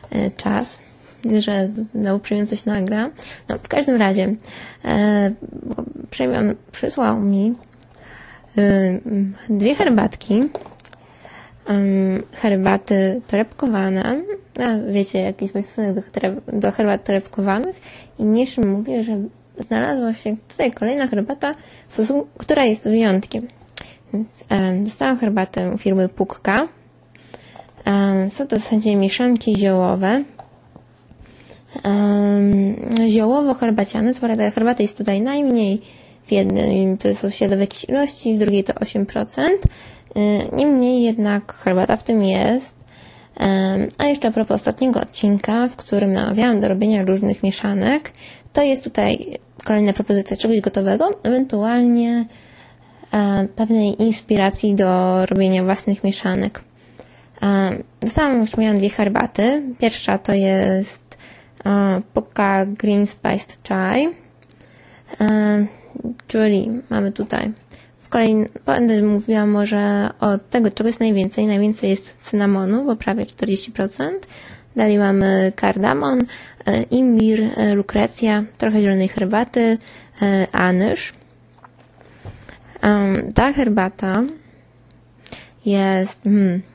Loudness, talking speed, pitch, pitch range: -19 LUFS, 110 wpm, 210 Hz, 200-230 Hz